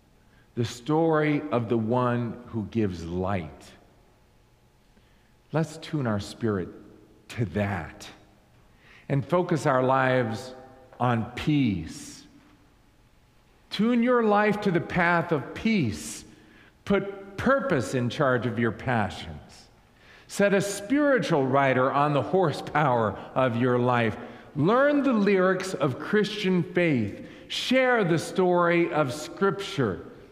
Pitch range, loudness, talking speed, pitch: 110-175 Hz, -25 LUFS, 110 wpm, 130 Hz